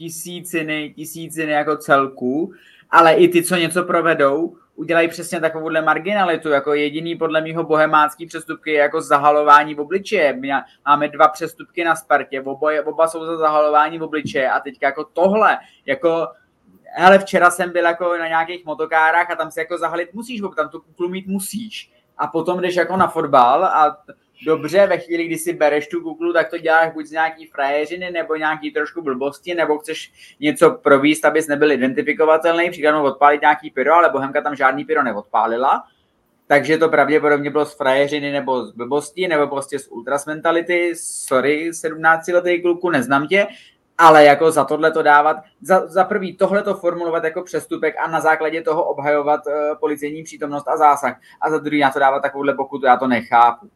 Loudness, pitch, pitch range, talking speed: -17 LUFS, 155 Hz, 150-170 Hz, 175 wpm